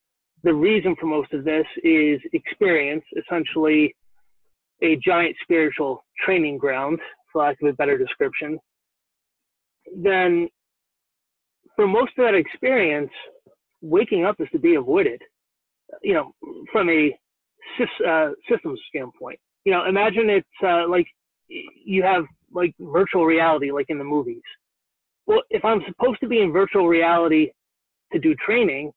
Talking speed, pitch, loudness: 135 wpm, 185 Hz, -21 LUFS